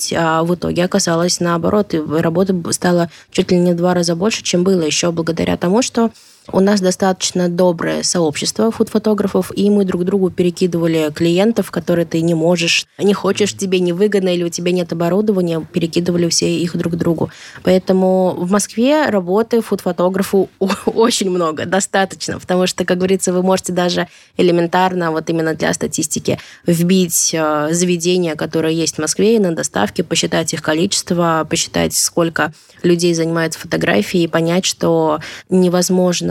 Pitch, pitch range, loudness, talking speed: 180 Hz, 165-190 Hz, -16 LUFS, 155 wpm